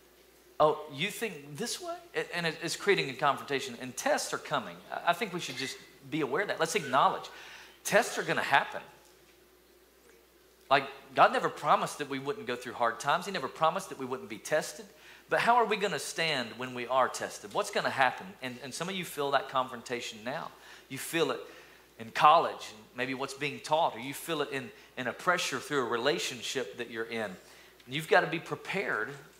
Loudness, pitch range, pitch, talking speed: -31 LUFS, 130-210 Hz, 150 Hz, 200 wpm